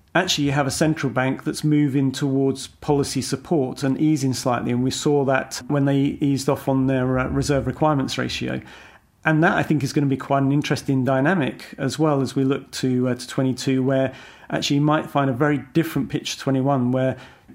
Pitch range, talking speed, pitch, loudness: 130-145 Hz, 205 wpm, 135 Hz, -21 LUFS